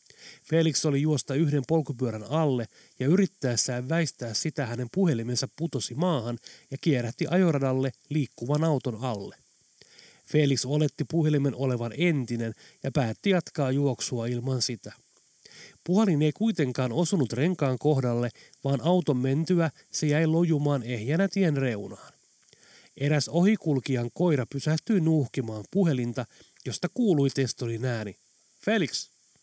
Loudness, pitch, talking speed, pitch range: -26 LUFS, 140 Hz, 115 wpm, 125-160 Hz